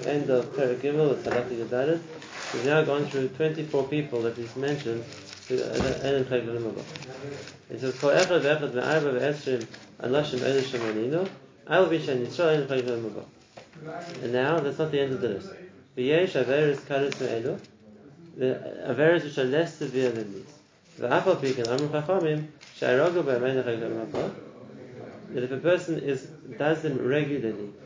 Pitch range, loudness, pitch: 125-155 Hz, -27 LUFS, 140 Hz